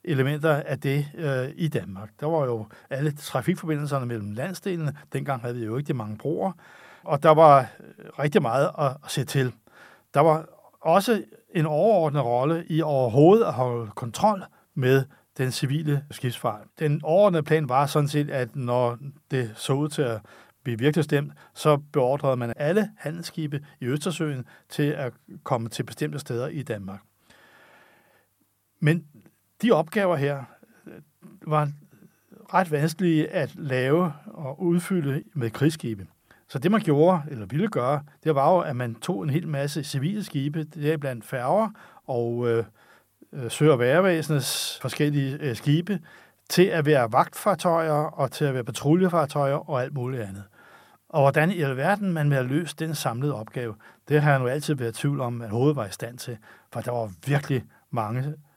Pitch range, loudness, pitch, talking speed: 130-160 Hz, -25 LUFS, 145 Hz, 165 wpm